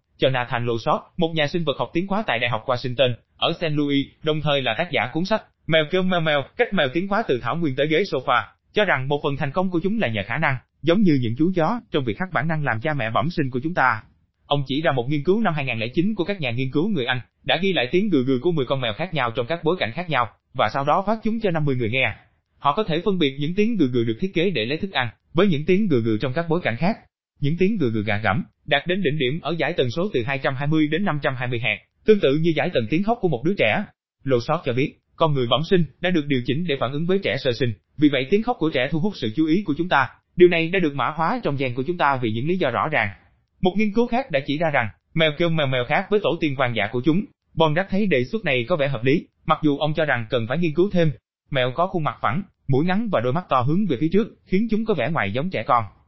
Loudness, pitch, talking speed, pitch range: -22 LUFS, 150 Hz, 295 wpm, 130-175 Hz